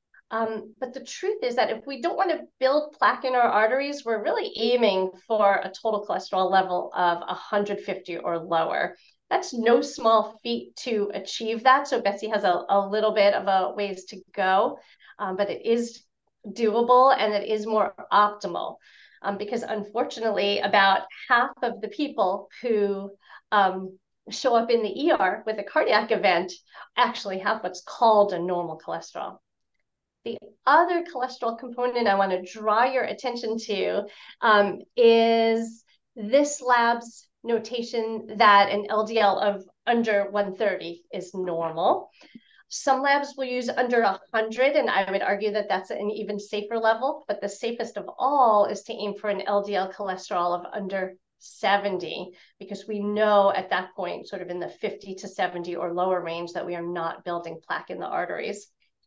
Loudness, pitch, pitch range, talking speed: -24 LUFS, 210 Hz, 195-235 Hz, 165 wpm